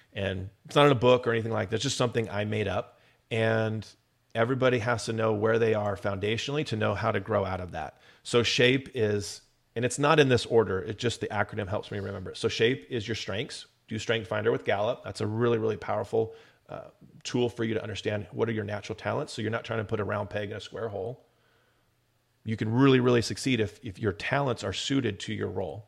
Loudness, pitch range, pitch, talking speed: -28 LUFS, 105-125 Hz, 110 Hz, 240 wpm